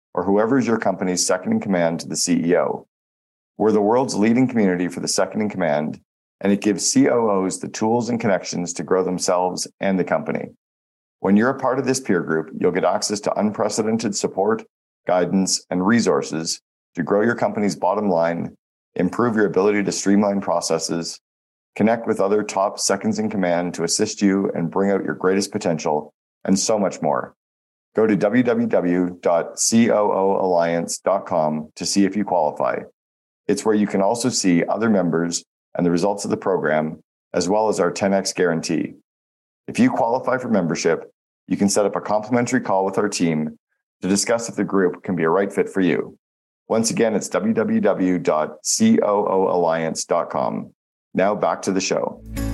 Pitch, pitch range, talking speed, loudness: 95 Hz, 85-105 Hz, 170 wpm, -20 LUFS